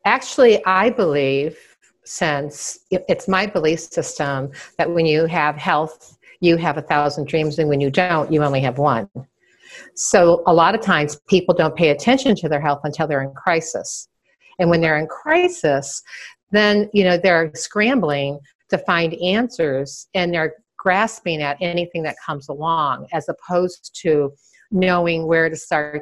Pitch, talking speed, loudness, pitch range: 165 Hz, 160 wpm, -19 LUFS, 150-185 Hz